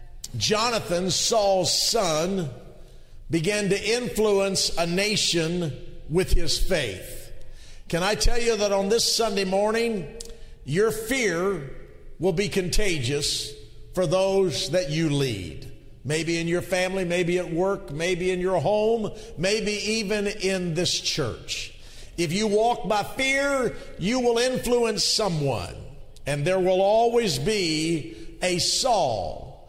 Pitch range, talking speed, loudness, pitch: 165-215 Hz, 125 wpm, -24 LUFS, 185 Hz